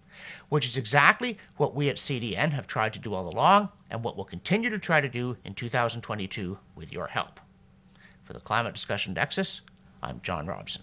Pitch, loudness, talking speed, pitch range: 125 Hz, -28 LUFS, 190 wpm, 105-150 Hz